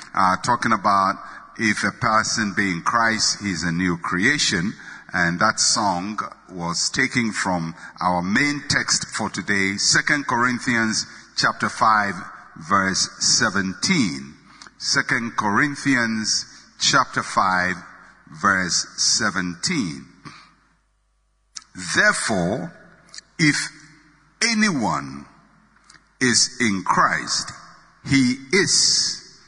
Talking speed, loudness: 90 wpm, -20 LUFS